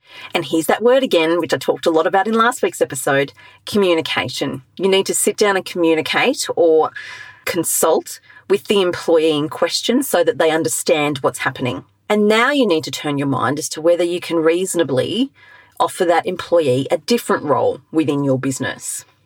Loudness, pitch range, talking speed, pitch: -17 LUFS, 160-255 Hz, 185 wpm, 185 Hz